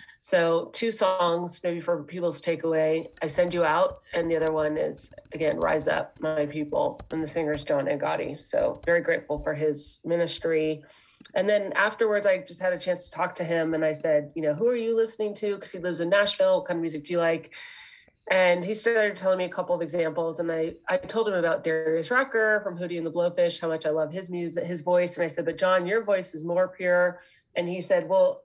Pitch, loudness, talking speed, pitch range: 175 Hz, -26 LUFS, 235 wpm, 165-200 Hz